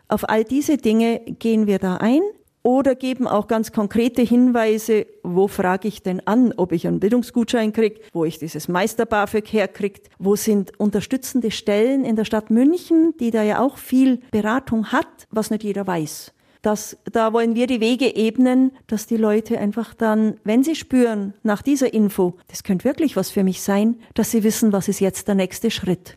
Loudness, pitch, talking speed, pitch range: -20 LUFS, 220 Hz, 190 wpm, 205-245 Hz